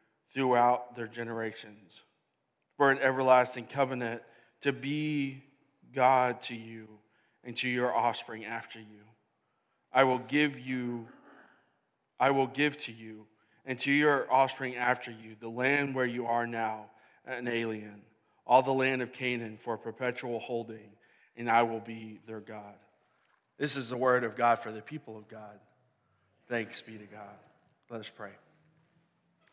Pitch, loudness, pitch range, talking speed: 120 Hz, -30 LUFS, 110-130 Hz, 150 wpm